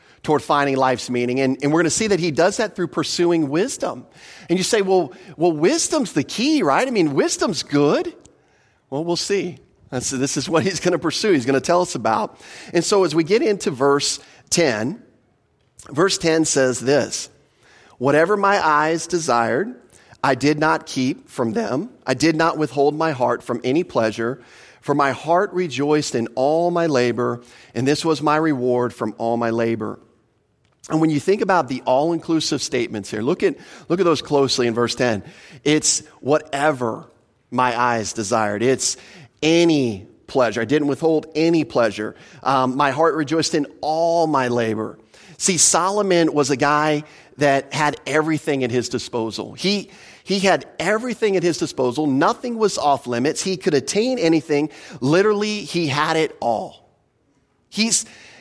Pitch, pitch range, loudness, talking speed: 150 Hz, 130-170 Hz, -19 LUFS, 170 wpm